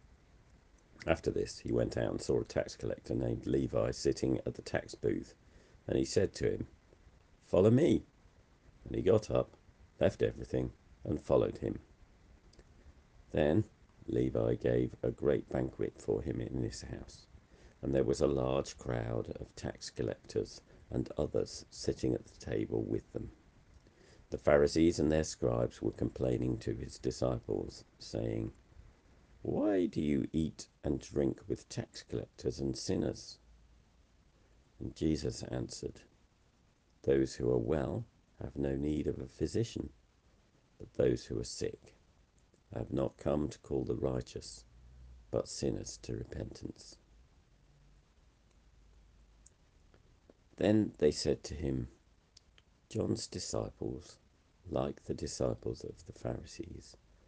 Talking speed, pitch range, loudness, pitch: 130 wpm, 65-85 Hz, -36 LUFS, 75 Hz